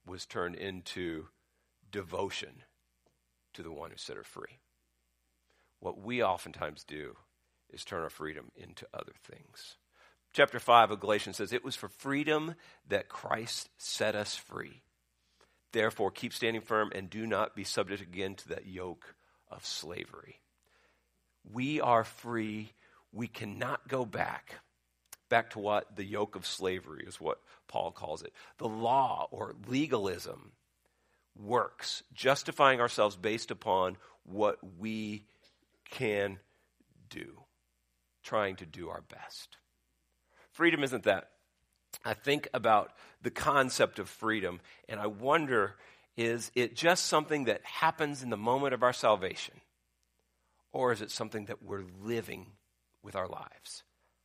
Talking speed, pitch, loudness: 135 wpm, 100 Hz, -33 LUFS